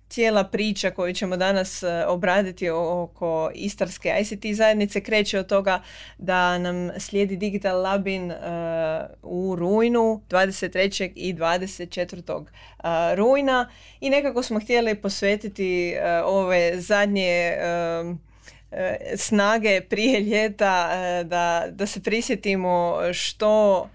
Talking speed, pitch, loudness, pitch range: 100 wpm, 190 Hz, -23 LUFS, 180-210 Hz